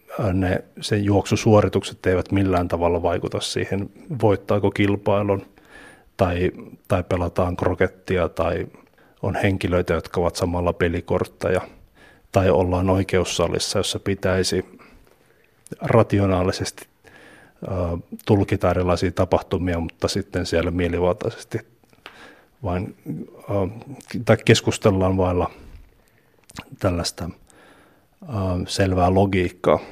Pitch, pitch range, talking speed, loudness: 95 Hz, 90-100 Hz, 80 wpm, -22 LUFS